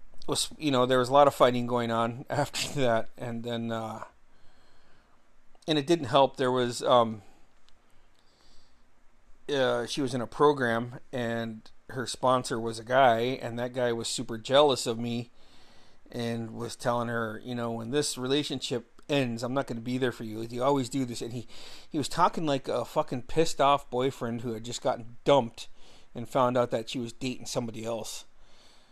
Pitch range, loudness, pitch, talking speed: 115-135 Hz, -28 LUFS, 120 Hz, 185 wpm